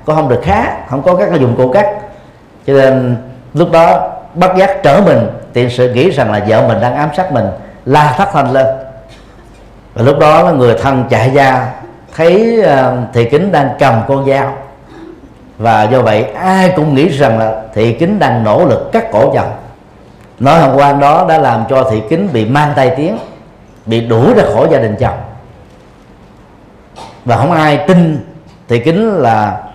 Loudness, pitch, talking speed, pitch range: -10 LUFS, 135 Hz, 185 wpm, 120-160 Hz